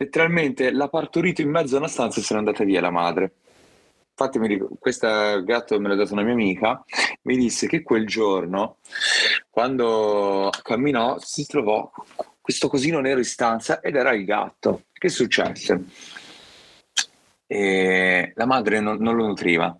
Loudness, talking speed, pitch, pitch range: -22 LUFS, 150 wpm, 115 Hz, 100-130 Hz